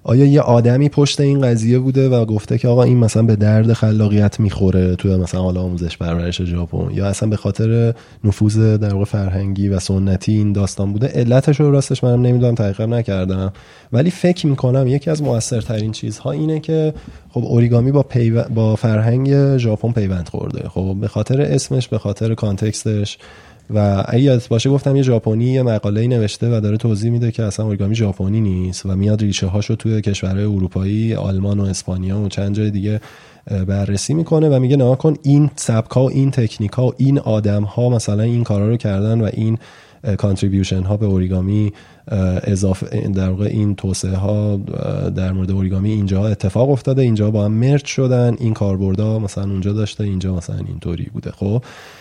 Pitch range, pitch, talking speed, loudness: 100-120 Hz, 110 Hz, 180 wpm, -17 LUFS